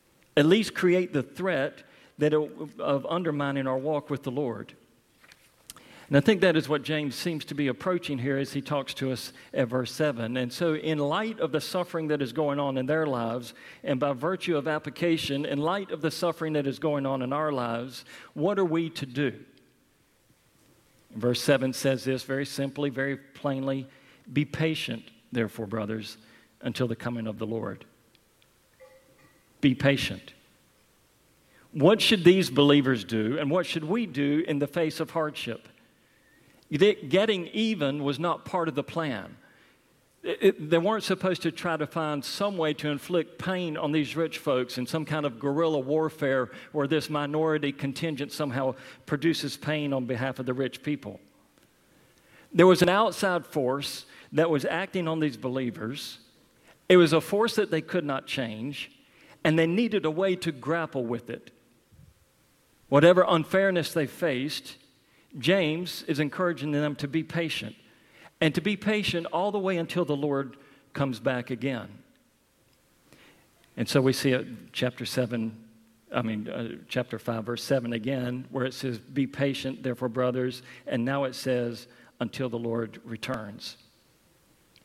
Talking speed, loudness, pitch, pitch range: 165 wpm, -27 LUFS, 145 Hz, 130-165 Hz